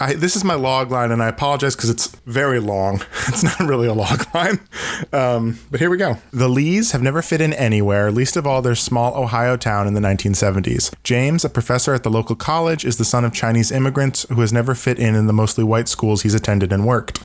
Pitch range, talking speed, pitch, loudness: 115-140 Hz, 235 wpm, 125 Hz, -18 LUFS